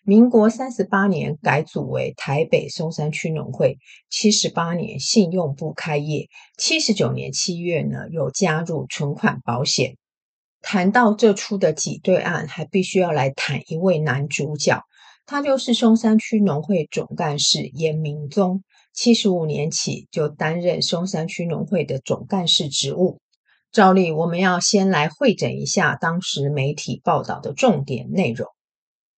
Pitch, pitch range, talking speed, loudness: 175 Hz, 150-200 Hz, 230 characters per minute, -20 LUFS